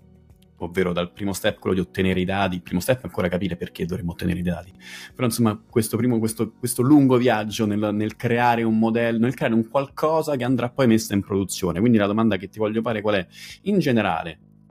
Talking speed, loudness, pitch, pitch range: 220 wpm, -22 LUFS, 110 Hz, 95-120 Hz